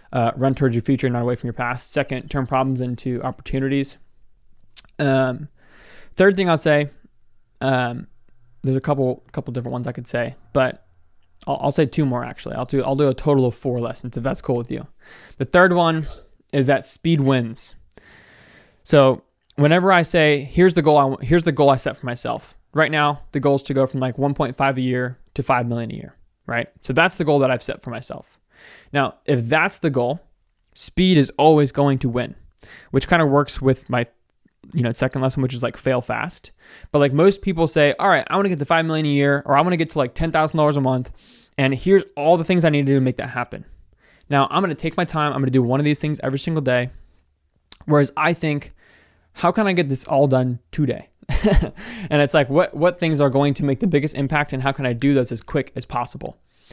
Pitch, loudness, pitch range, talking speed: 140 Hz, -20 LUFS, 125-150 Hz, 230 wpm